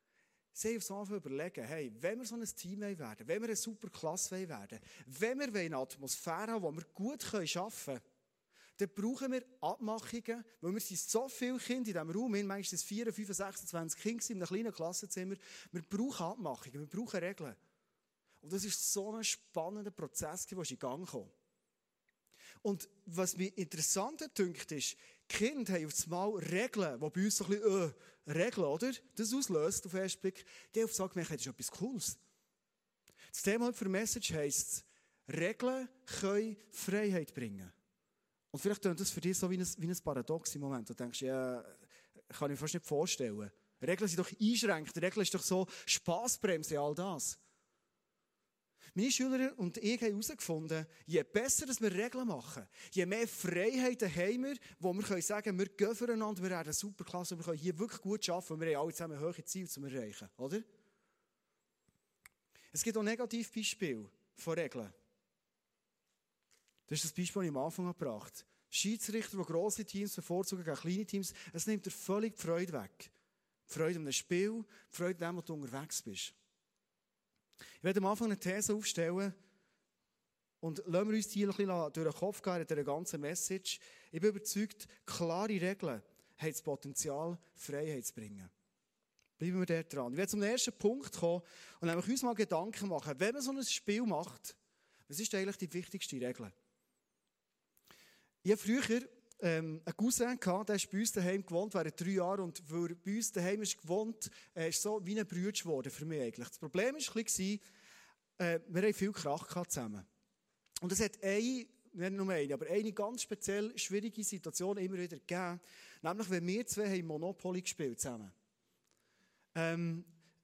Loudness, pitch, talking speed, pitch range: -38 LUFS, 190 Hz, 175 wpm, 165-210 Hz